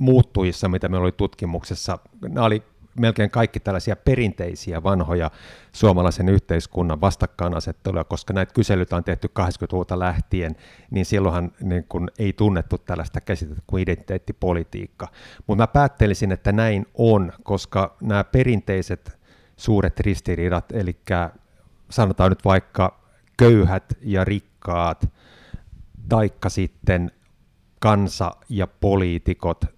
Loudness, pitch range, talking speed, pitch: -22 LUFS, 90-105 Hz, 110 wpm, 95 Hz